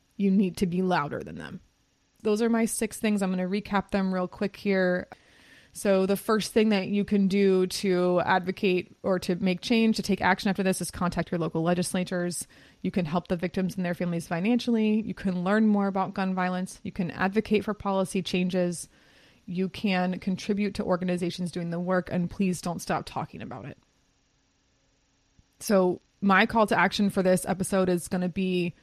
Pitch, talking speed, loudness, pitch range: 190 Hz, 195 wpm, -27 LUFS, 180-200 Hz